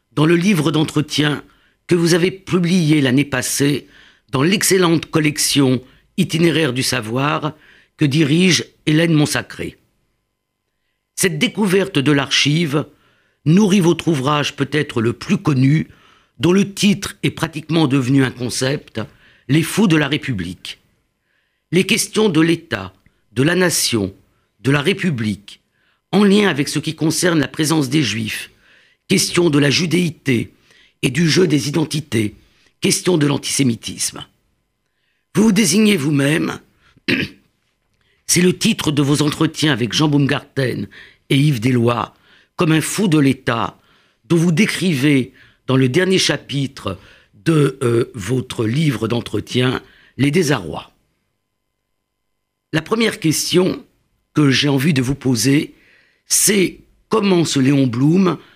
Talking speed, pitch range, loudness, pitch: 130 wpm, 130-170 Hz, -17 LUFS, 150 Hz